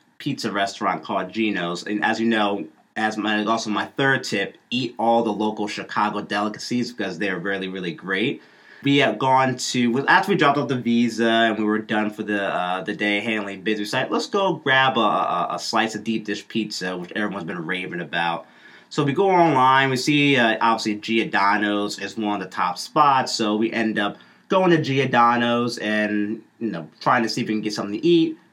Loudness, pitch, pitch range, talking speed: -21 LUFS, 110 Hz, 105-125 Hz, 205 wpm